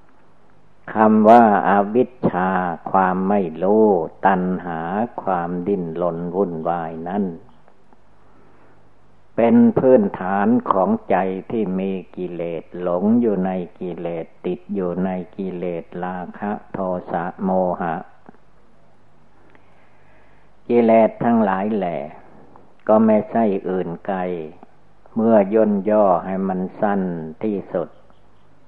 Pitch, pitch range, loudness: 95 Hz, 90-110 Hz, -19 LUFS